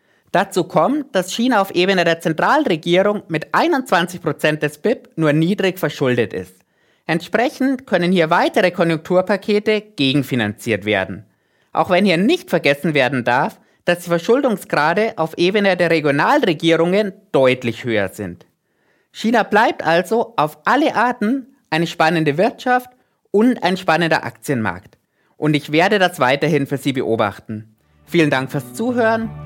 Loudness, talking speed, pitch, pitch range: -17 LUFS, 130 wpm, 170 Hz, 140-205 Hz